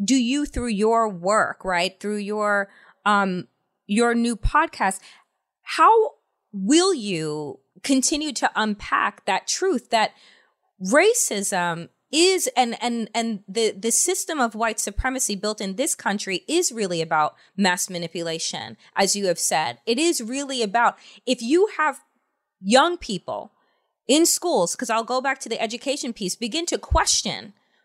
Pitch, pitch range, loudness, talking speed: 230 Hz, 195-270 Hz, -22 LUFS, 145 wpm